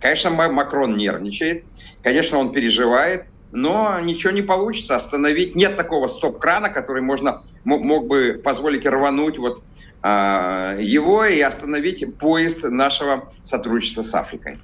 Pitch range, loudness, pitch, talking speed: 125-165 Hz, -19 LUFS, 140 Hz, 120 wpm